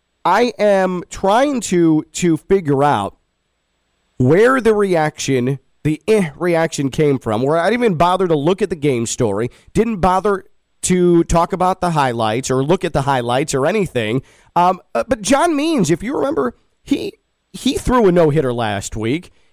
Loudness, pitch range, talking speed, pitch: -16 LUFS, 130-195 Hz, 165 wpm, 170 Hz